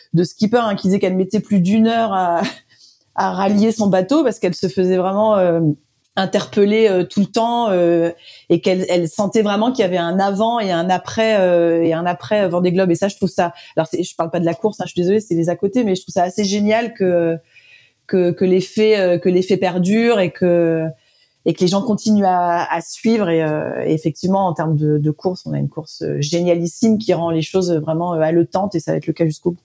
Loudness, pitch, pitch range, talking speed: -17 LUFS, 185 Hz, 170-205 Hz, 235 wpm